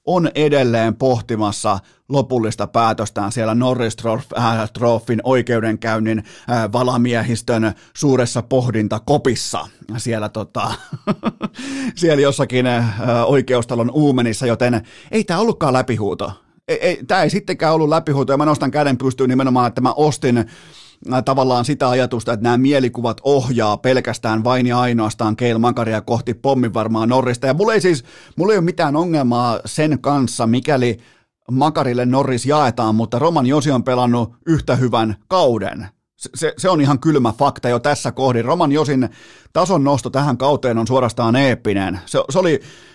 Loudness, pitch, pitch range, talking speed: -17 LUFS, 125 Hz, 115-140 Hz, 140 wpm